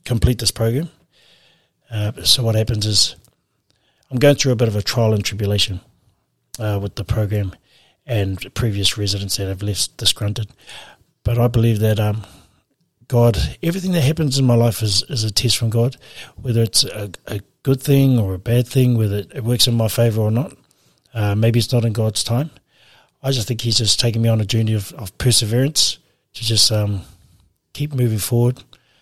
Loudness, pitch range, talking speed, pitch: -18 LUFS, 105-125 Hz, 190 wpm, 115 Hz